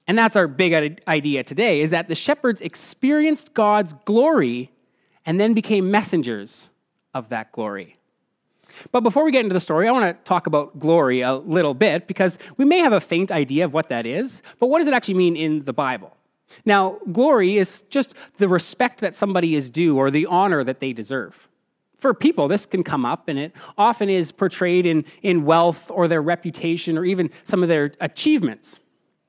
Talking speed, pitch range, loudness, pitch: 195 wpm, 160-215 Hz, -20 LUFS, 180 Hz